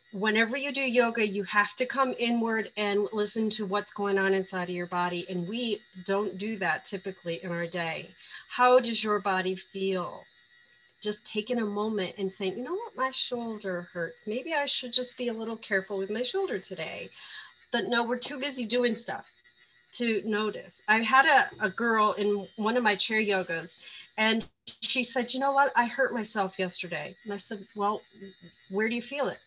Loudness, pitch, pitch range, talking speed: -28 LUFS, 210 Hz, 195-240 Hz, 195 wpm